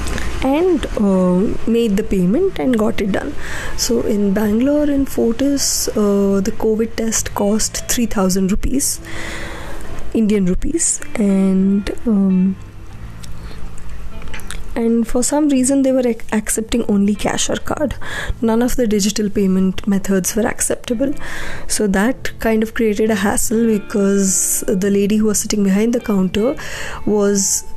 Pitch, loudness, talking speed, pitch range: 215 Hz, -17 LUFS, 135 wpm, 195-235 Hz